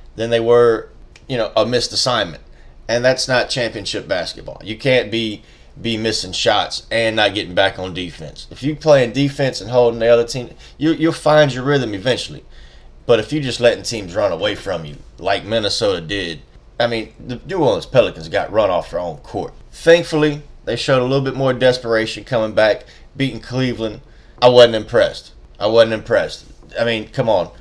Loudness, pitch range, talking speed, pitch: -17 LUFS, 110-135 Hz, 190 wpm, 120 Hz